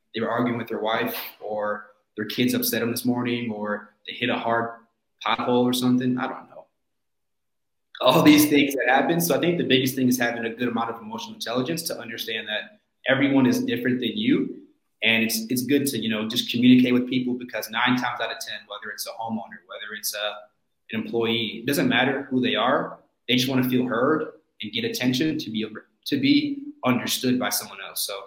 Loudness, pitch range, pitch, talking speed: -23 LUFS, 115-130 Hz, 125 Hz, 215 wpm